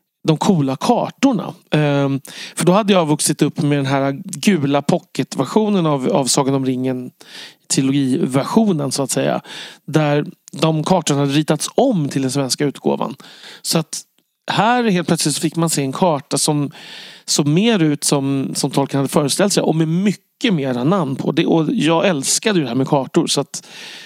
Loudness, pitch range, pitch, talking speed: -17 LUFS, 140-180 Hz, 155 Hz, 175 wpm